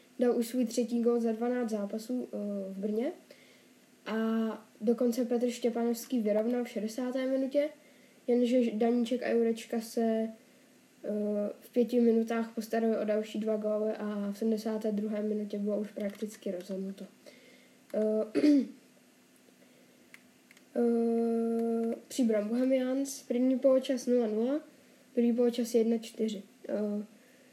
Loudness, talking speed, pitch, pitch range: -31 LUFS, 100 wpm, 230 Hz, 215-250 Hz